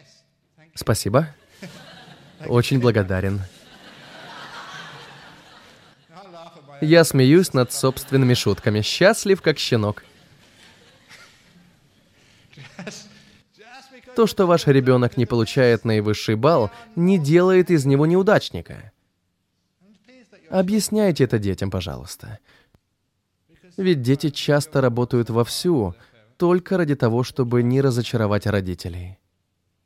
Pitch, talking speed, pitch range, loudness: 130 Hz, 80 wpm, 105-170 Hz, -19 LUFS